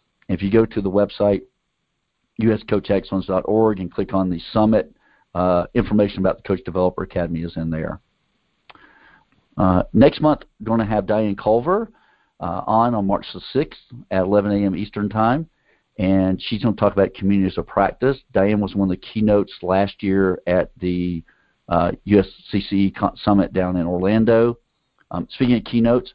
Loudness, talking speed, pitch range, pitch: -20 LUFS, 165 wpm, 95-110 Hz, 100 Hz